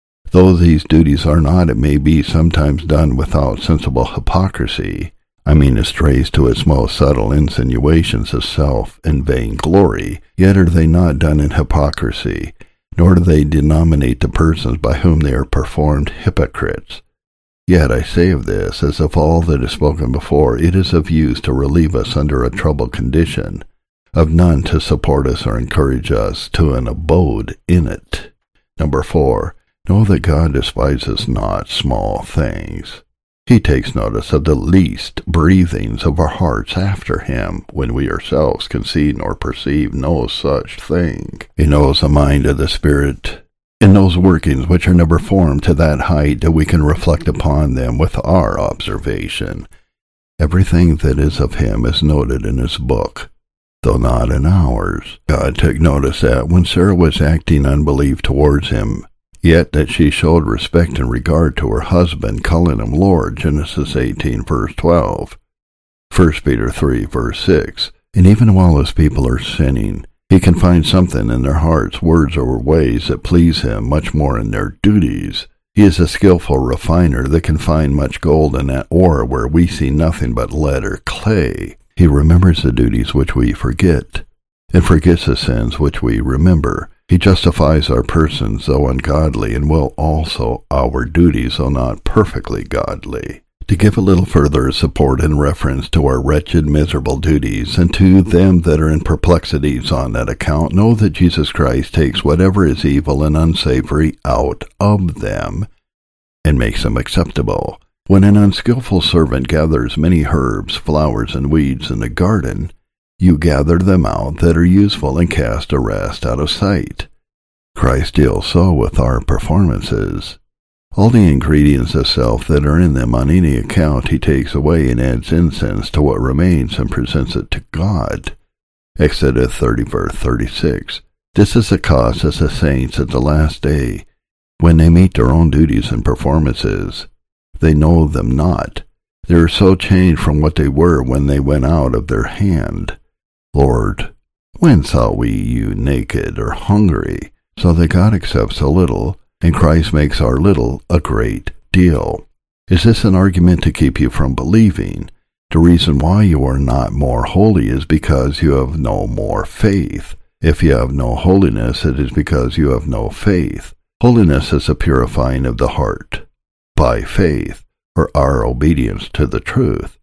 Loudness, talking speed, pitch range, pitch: -13 LUFS, 165 wpm, 70-90 Hz, 80 Hz